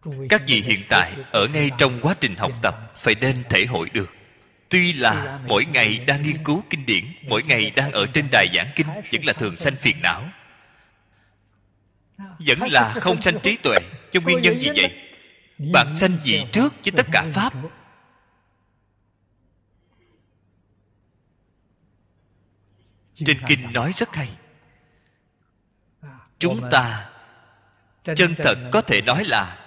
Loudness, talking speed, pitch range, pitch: -19 LUFS, 145 wpm, 100-150 Hz, 120 Hz